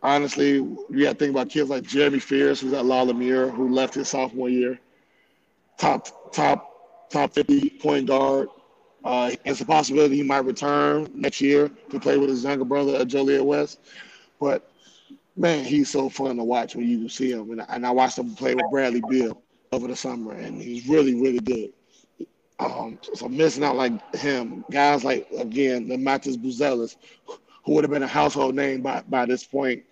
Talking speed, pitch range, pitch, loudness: 190 wpm, 130-145 Hz, 135 Hz, -23 LUFS